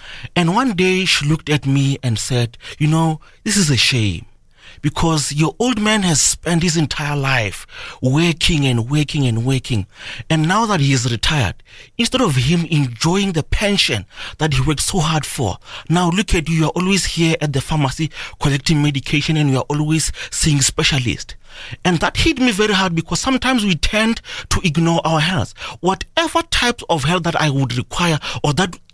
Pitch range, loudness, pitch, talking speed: 135-180 Hz, -17 LUFS, 155 Hz, 185 wpm